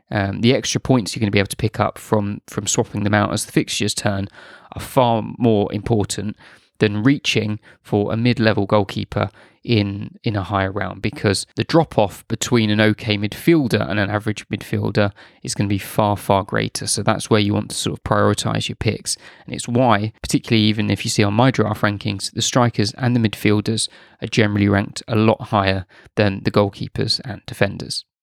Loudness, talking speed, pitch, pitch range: -19 LUFS, 200 wpm, 105 Hz, 105-115 Hz